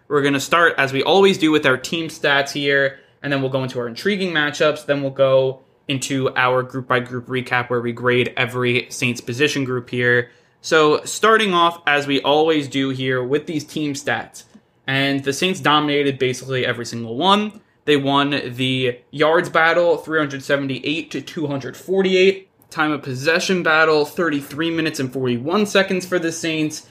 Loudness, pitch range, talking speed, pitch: -19 LUFS, 130-160 Hz, 175 wpm, 140 Hz